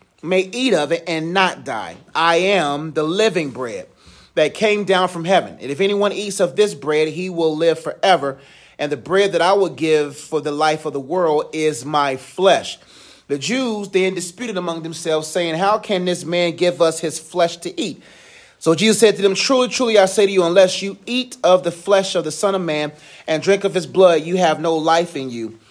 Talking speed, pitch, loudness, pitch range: 220 wpm, 175 Hz, -18 LUFS, 155-195 Hz